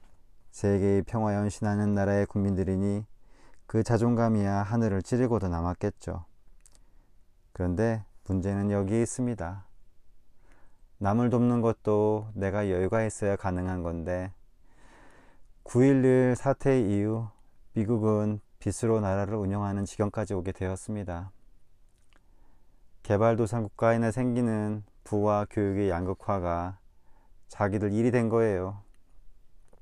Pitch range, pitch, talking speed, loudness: 95-115 Hz, 100 Hz, 245 characters per minute, -28 LUFS